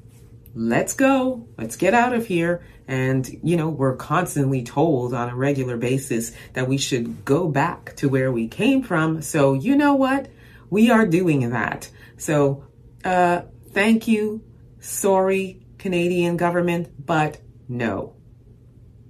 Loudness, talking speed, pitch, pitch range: -21 LUFS, 140 wpm, 140 Hz, 120-175 Hz